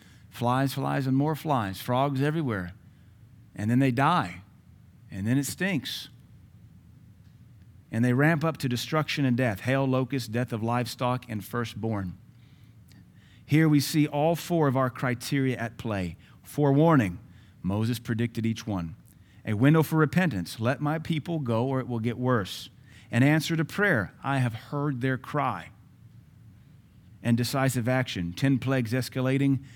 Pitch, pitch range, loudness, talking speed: 125 Hz, 110-135 Hz, -27 LUFS, 145 wpm